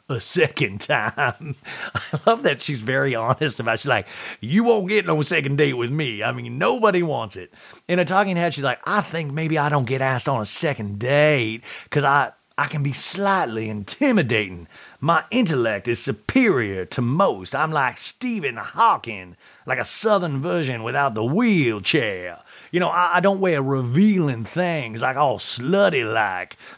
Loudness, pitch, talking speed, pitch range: -21 LUFS, 145 Hz, 175 wpm, 125-180 Hz